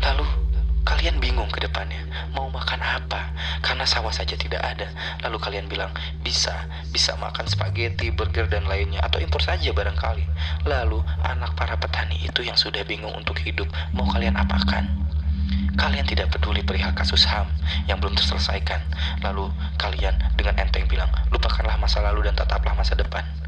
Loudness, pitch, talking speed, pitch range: -24 LUFS, 75 Hz, 150 wpm, 70-80 Hz